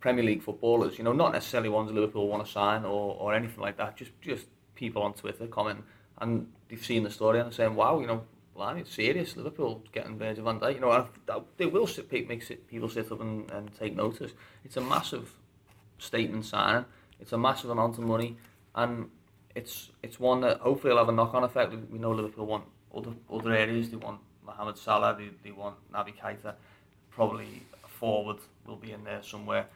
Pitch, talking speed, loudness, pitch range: 110 Hz, 200 wpm, -30 LUFS, 105-115 Hz